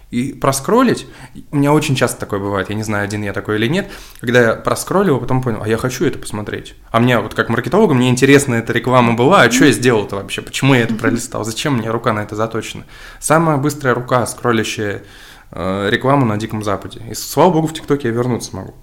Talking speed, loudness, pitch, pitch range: 220 wpm, -15 LUFS, 120 Hz, 105-135 Hz